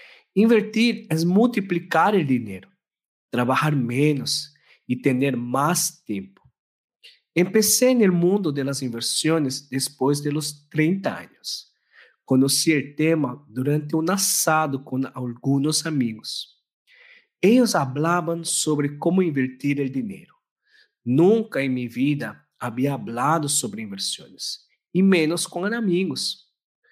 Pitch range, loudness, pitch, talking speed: 135-190 Hz, -22 LUFS, 155 Hz, 115 wpm